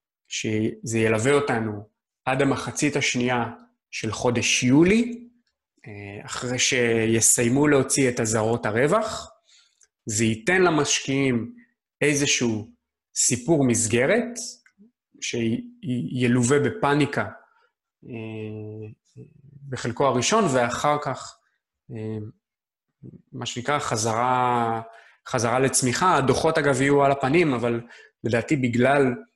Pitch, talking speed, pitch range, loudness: 125 Hz, 80 wpm, 115-145 Hz, -22 LUFS